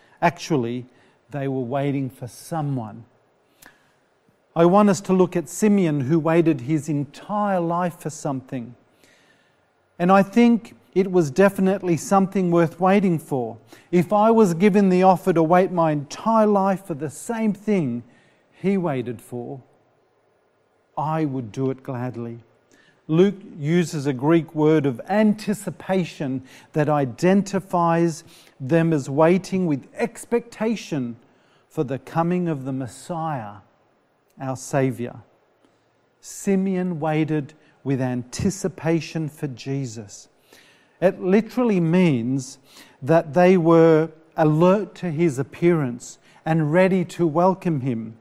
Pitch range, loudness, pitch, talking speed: 135-185 Hz, -21 LUFS, 165 Hz, 120 wpm